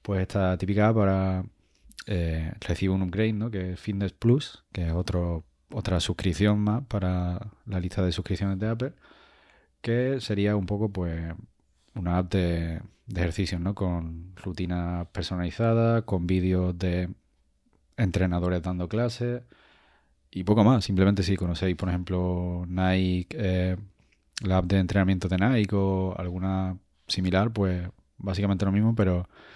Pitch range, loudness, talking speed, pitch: 90-100 Hz, -27 LUFS, 140 wpm, 95 Hz